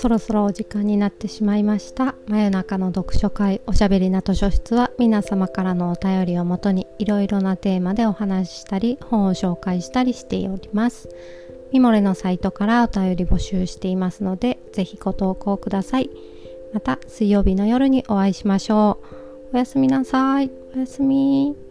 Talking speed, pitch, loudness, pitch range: 370 characters per minute, 205 Hz, -21 LUFS, 190-235 Hz